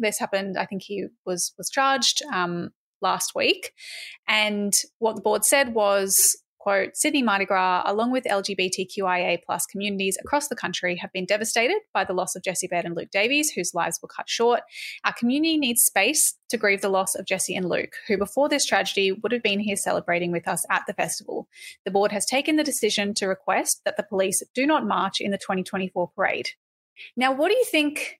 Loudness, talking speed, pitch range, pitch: -23 LUFS, 200 wpm, 190-270 Hz, 205 Hz